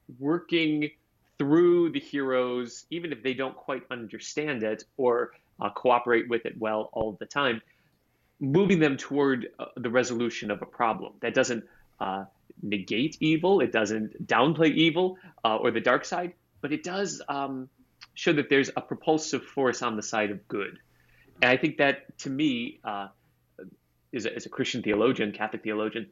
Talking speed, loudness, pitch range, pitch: 170 wpm, -27 LUFS, 115-160 Hz, 130 Hz